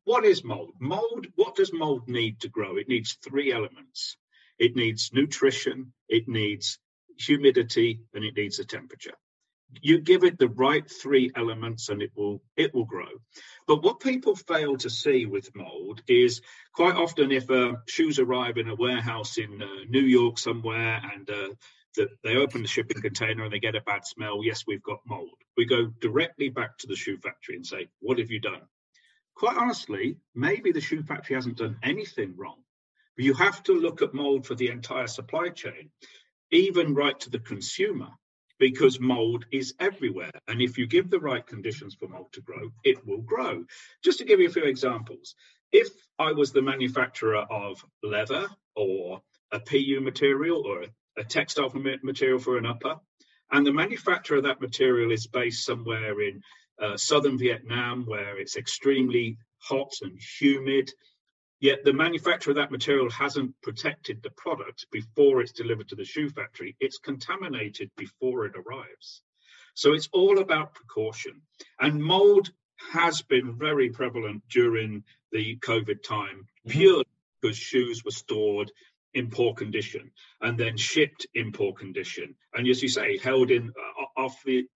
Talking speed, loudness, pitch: 170 wpm, -26 LUFS, 135 Hz